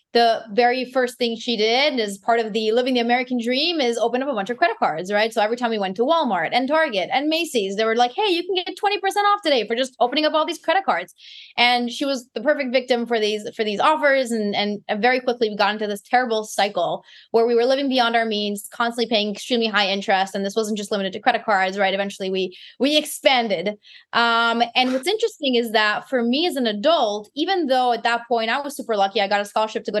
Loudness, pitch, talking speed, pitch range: -20 LUFS, 235 Hz, 250 wpm, 215-265 Hz